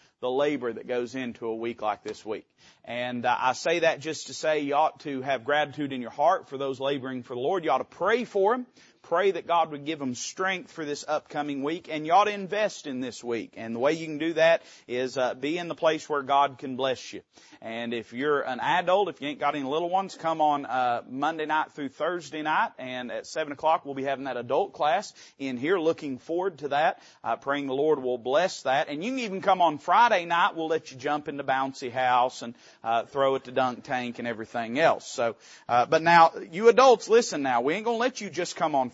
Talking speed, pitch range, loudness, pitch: 245 wpm, 130-165 Hz, -27 LUFS, 145 Hz